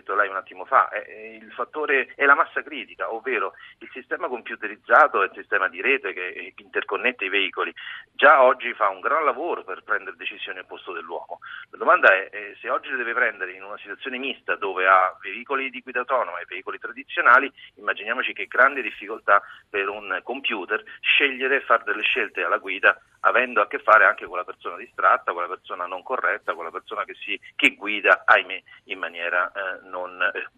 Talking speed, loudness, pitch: 190 wpm, -22 LUFS, 150 Hz